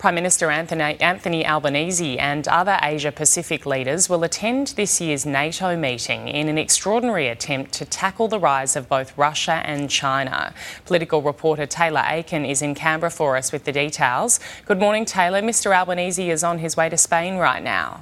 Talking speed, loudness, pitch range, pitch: 175 wpm, -20 LUFS, 145-180 Hz, 160 Hz